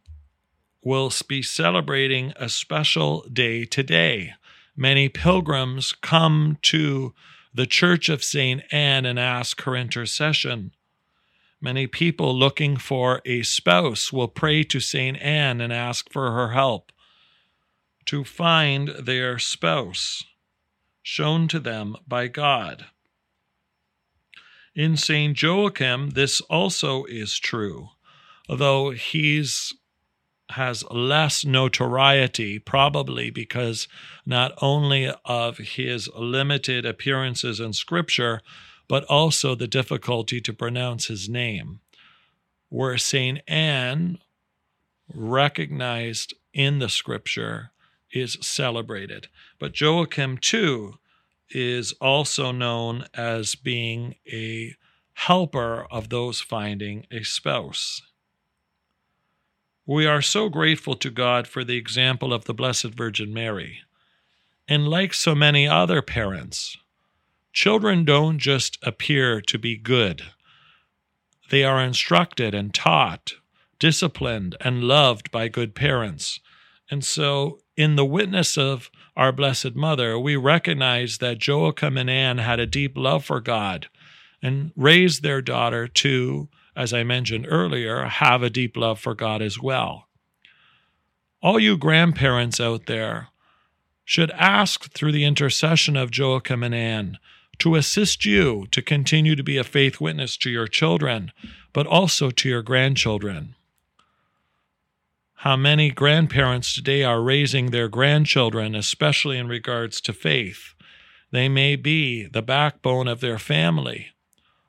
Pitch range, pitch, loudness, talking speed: 120-150 Hz, 130 Hz, -21 LUFS, 120 wpm